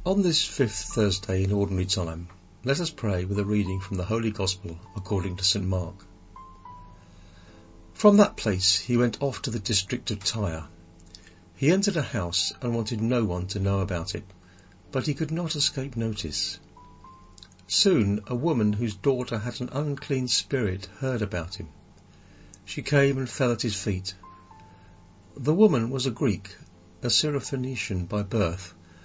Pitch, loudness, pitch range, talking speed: 100 Hz, -26 LUFS, 90-125 Hz, 160 wpm